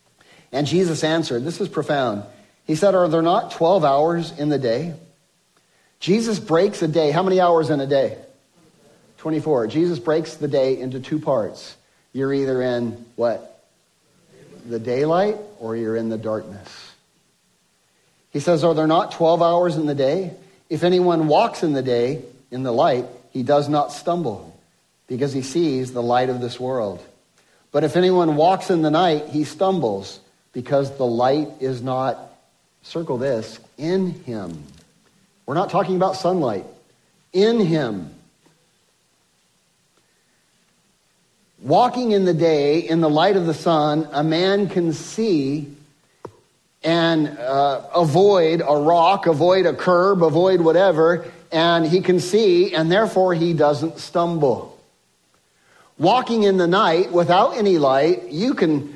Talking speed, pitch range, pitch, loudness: 145 wpm, 135-175 Hz, 160 Hz, -19 LUFS